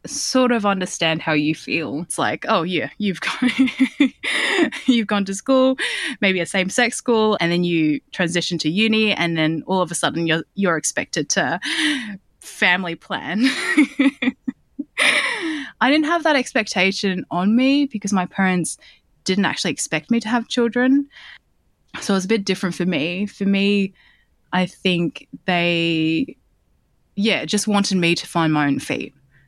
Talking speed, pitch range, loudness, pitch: 160 wpm, 175-255 Hz, -19 LUFS, 200 Hz